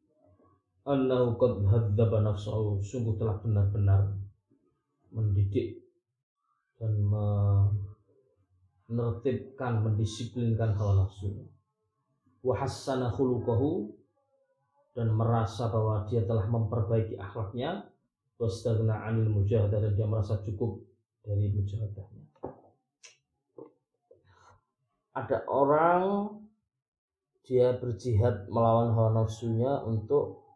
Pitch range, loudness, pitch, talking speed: 105-125 Hz, -29 LUFS, 115 Hz, 70 wpm